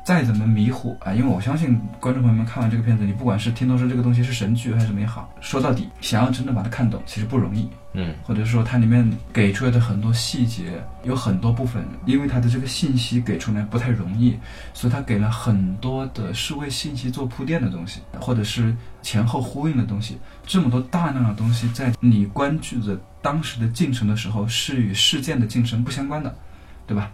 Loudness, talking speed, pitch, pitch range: -22 LUFS, 345 characters per minute, 120 Hz, 110-125 Hz